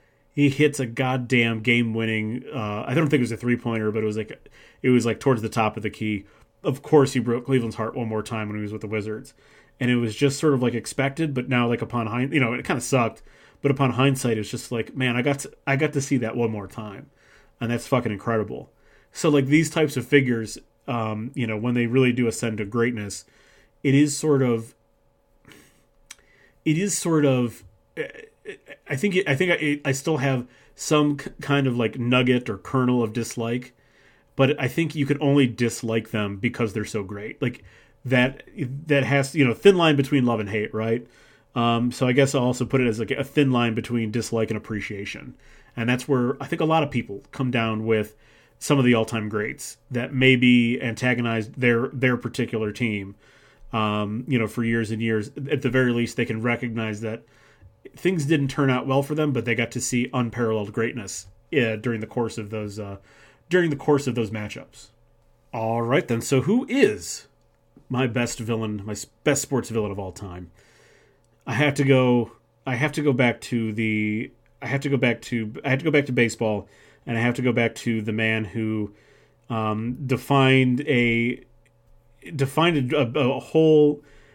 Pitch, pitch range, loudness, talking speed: 120 Hz, 110-140 Hz, -23 LUFS, 205 wpm